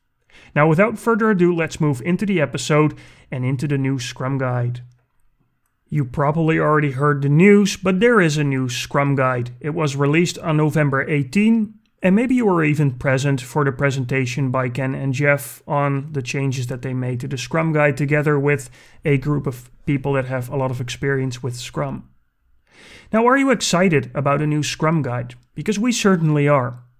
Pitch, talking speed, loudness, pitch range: 145 Hz, 185 wpm, -19 LUFS, 130-160 Hz